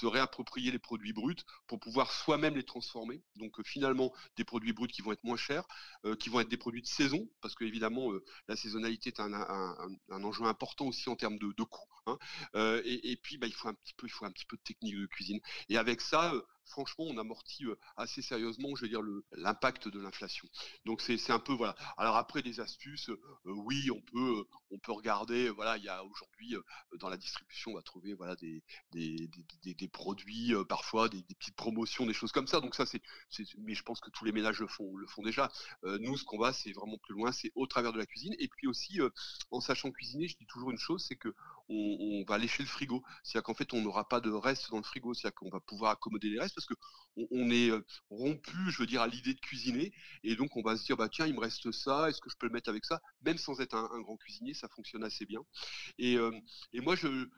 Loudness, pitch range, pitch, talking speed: -37 LUFS, 110-130 Hz, 115 Hz, 255 wpm